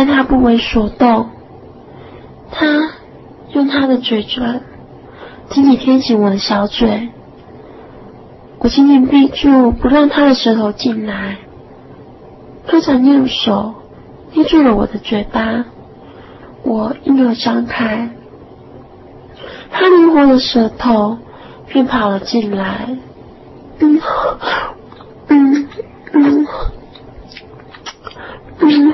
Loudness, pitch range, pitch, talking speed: -13 LUFS, 230-285 Hz, 260 Hz, 135 characters per minute